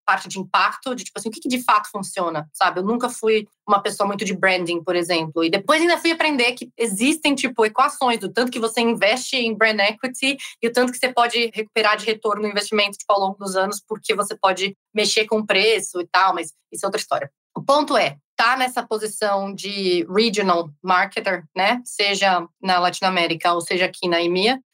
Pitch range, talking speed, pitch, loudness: 190-235 Hz, 210 wpm, 210 Hz, -20 LUFS